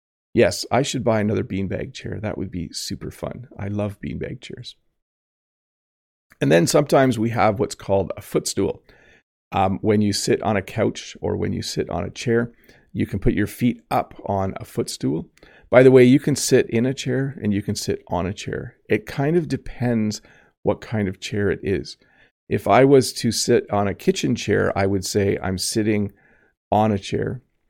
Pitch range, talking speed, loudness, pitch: 95-120 Hz, 195 wpm, -21 LUFS, 105 Hz